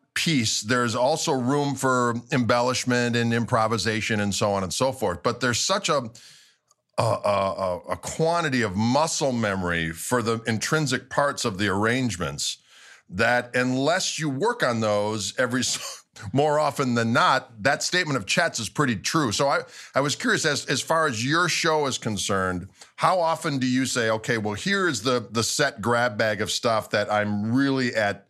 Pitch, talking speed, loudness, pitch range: 120 Hz, 180 wpm, -24 LUFS, 110-135 Hz